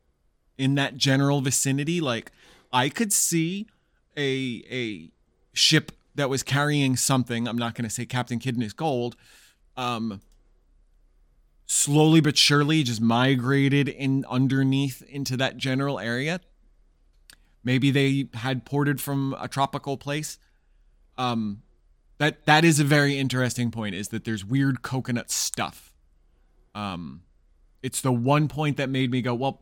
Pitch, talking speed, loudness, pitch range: 130 Hz, 135 wpm, -24 LUFS, 115-140 Hz